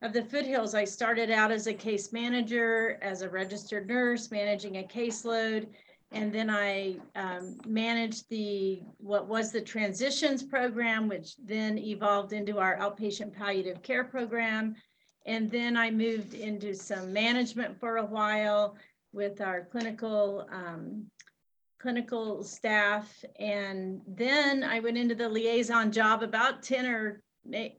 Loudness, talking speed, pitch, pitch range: -31 LUFS, 140 wpm, 220 Hz, 205-230 Hz